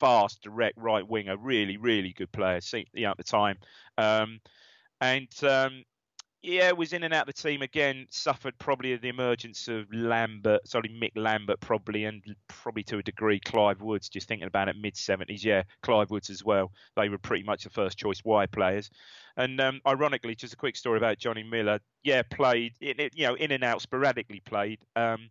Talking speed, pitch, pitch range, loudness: 190 wpm, 110 Hz, 105-125 Hz, -29 LUFS